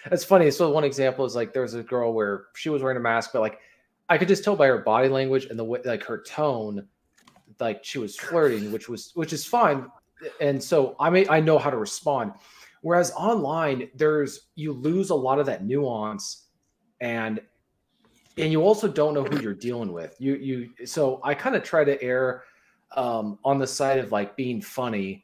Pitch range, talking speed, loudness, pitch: 120-155 Hz, 205 wpm, -24 LUFS, 135 Hz